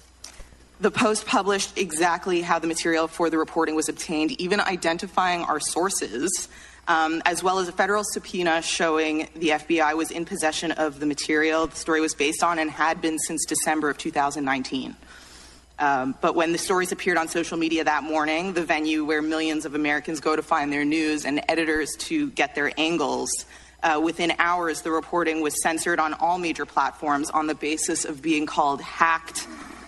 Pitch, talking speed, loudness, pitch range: 160 Hz, 180 wpm, -24 LUFS, 155-170 Hz